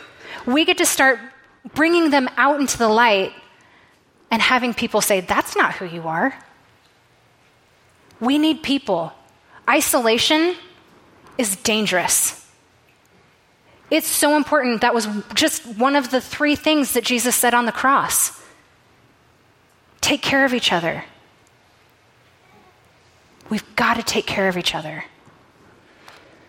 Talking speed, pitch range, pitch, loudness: 125 wpm, 225-295 Hz, 255 Hz, -18 LUFS